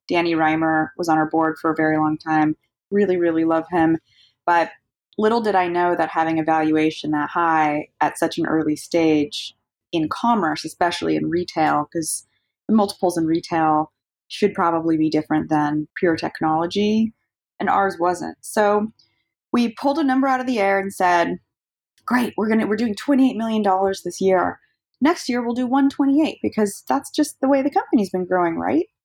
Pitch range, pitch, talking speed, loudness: 155-220 Hz, 175 Hz, 180 wpm, -20 LUFS